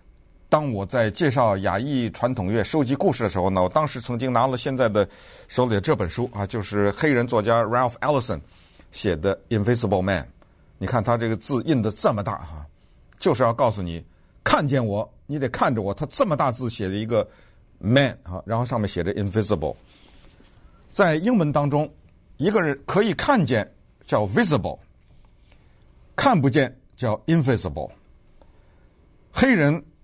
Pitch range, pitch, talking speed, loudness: 95-130 Hz, 115 Hz, 310 characters per minute, -22 LUFS